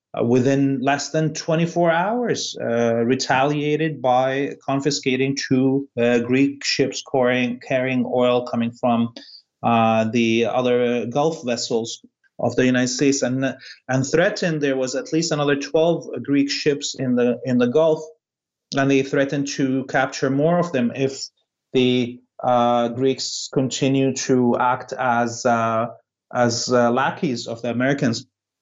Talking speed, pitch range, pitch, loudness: 135 wpm, 120-140 Hz, 130 Hz, -20 LUFS